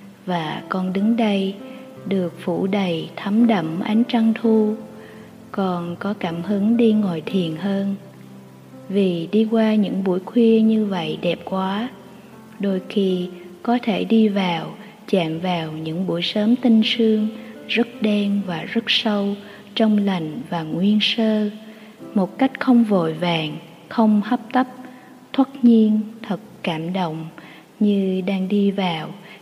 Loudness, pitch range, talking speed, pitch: -20 LUFS, 180-225 Hz, 145 wpm, 205 Hz